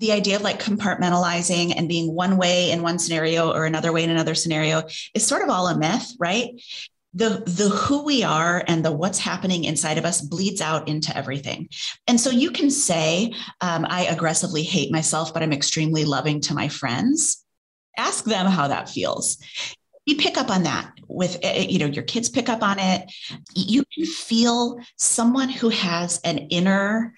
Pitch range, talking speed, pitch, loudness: 160-225 Hz, 190 wpm, 180 Hz, -21 LUFS